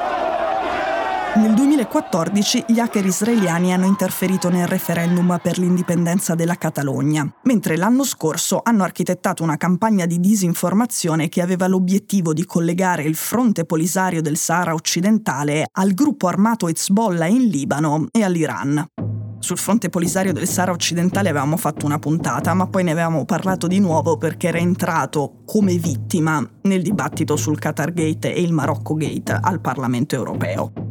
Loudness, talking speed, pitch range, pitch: -19 LUFS, 145 wpm, 155-195 Hz, 175 Hz